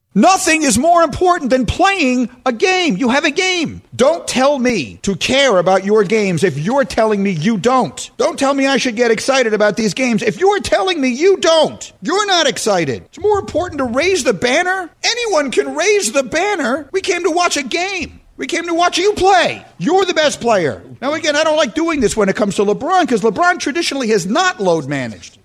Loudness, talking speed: -14 LUFS, 215 wpm